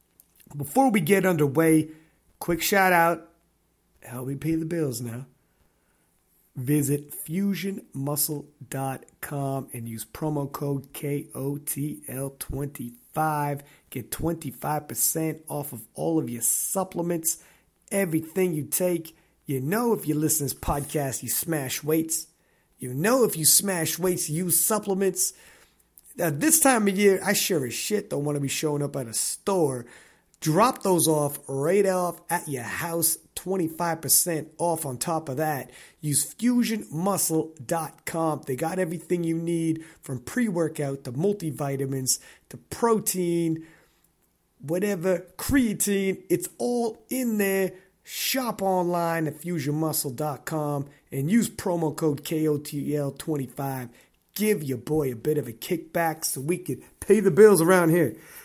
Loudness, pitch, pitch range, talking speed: -25 LUFS, 160 Hz, 145-180 Hz, 130 wpm